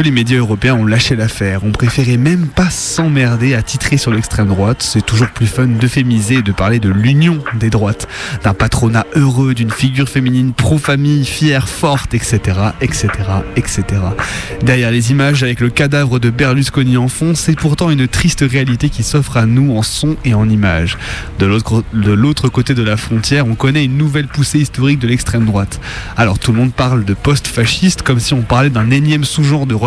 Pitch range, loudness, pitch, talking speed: 110-140 Hz, -13 LUFS, 125 Hz, 195 wpm